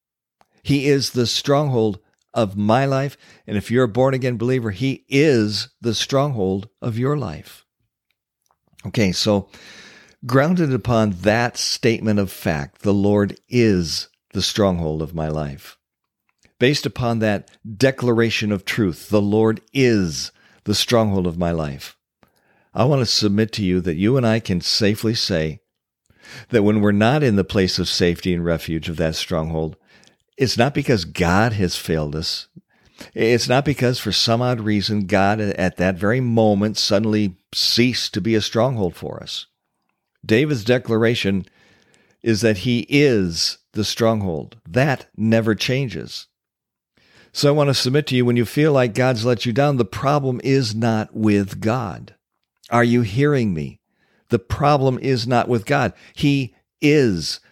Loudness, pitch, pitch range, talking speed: -19 LUFS, 110 Hz, 100-125 Hz, 155 wpm